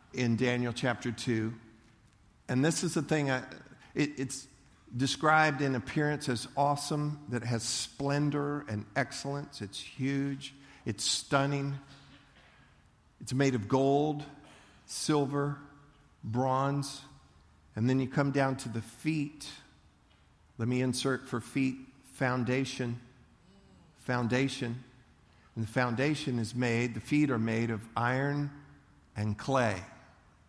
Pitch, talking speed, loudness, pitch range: 130 Hz, 120 wpm, -32 LUFS, 115-140 Hz